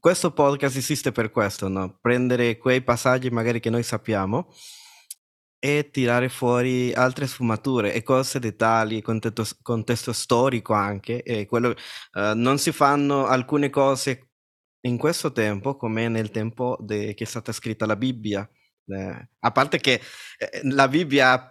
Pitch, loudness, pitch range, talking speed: 120 Hz, -23 LUFS, 110-135 Hz, 150 wpm